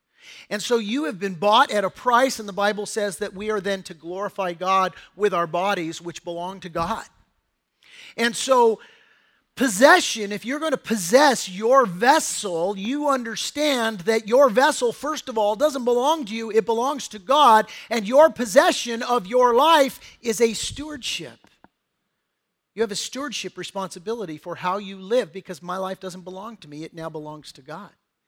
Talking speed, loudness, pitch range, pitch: 175 wpm, -21 LUFS, 190-255 Hz, 220 Hz